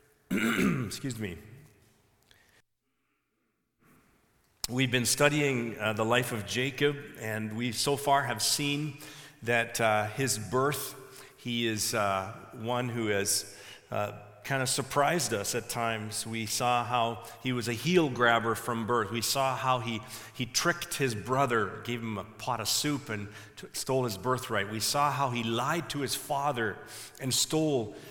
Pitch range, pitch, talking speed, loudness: 110-135 Hz, 120 Hz, 155 wpm, -30 LUFS